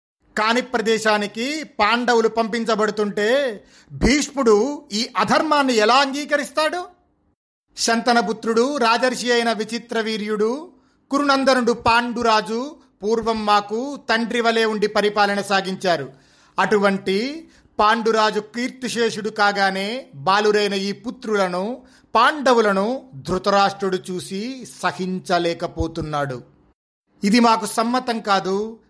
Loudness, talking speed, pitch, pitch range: -20 LUFS, 80 wpm, 225 Hz, 200-245 Hz